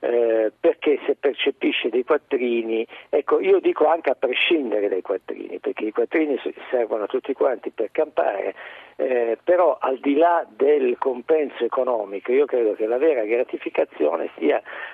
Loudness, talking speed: -22 LUFS, 155 wpm